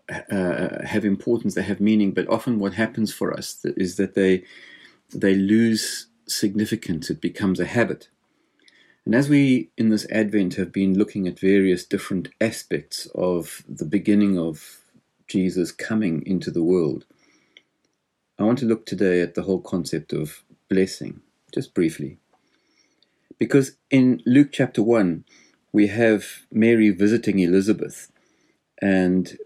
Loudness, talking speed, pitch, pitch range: -22 LUFS, 140 wpm, 100 Hz, 95-110 Hz